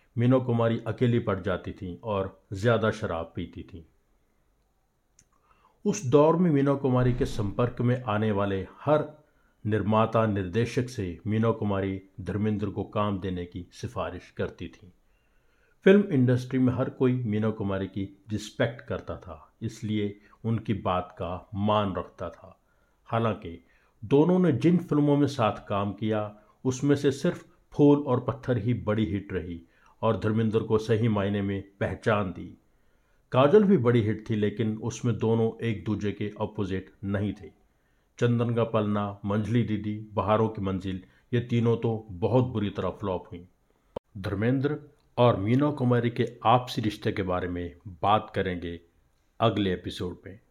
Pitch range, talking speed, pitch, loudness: 95-120 Hz, 150 wpm, 110 Hz, -27 LUFS